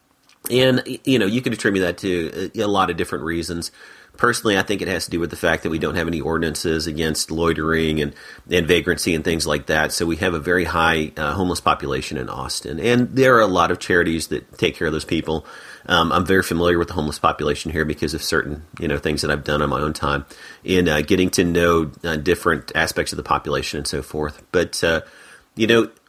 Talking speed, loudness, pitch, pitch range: 235 wpm, -20 LUFS, 85 Hz, 75-90 Hz